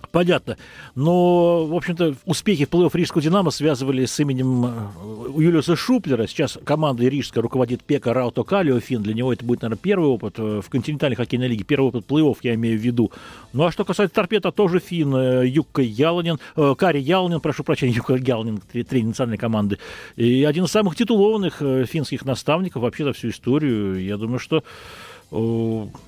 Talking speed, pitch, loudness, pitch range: 170 wpm, 135 Hz, -21 LUFS, 120-165 Hz